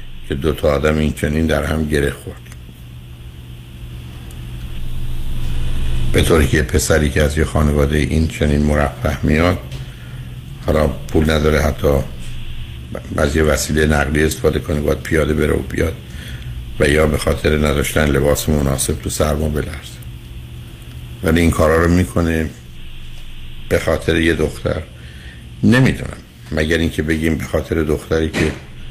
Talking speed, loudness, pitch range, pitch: 130 wpm, -17 LUFS, 60-80 Hz, 75 Hz